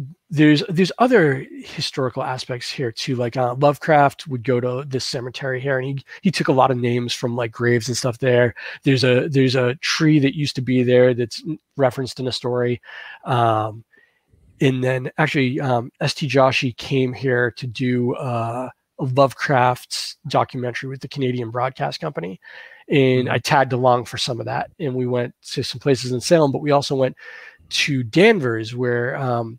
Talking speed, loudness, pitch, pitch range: 180 wpm, -20 LUFS, 130 Hz, 125-140 Hz